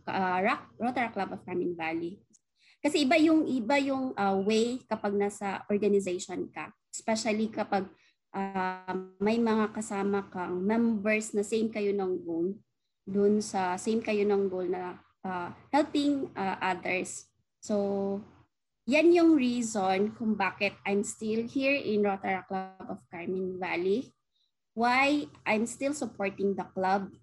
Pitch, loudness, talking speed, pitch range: 205 Hz, -30 LUFS, 135 wpm, 190-230 Hz